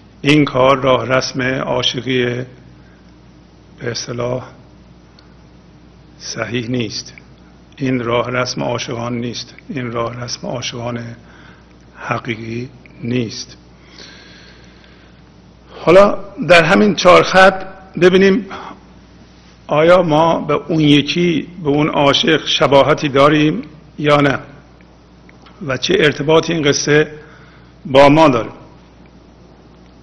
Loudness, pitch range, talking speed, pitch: -14 LUFS, 105-150 Hz, 90 wpm, 125 Hz